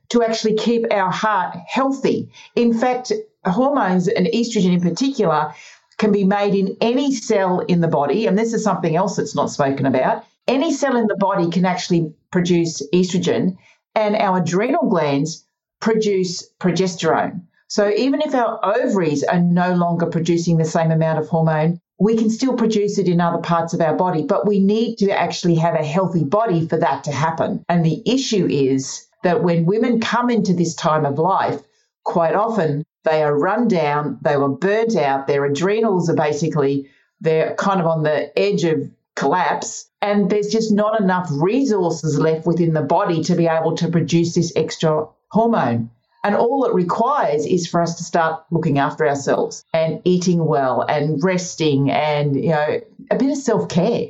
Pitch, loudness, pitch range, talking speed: 180 Hz, -18 LUFS, 160-215 Hz, 180 wpm